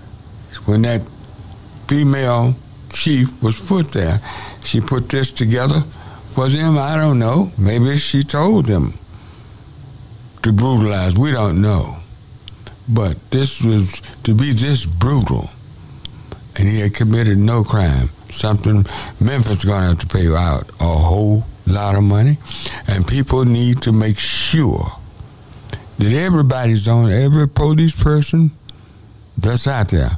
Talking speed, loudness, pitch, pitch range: 135 wpm, -16 LUFS, 115 Hz, 100-130 Hz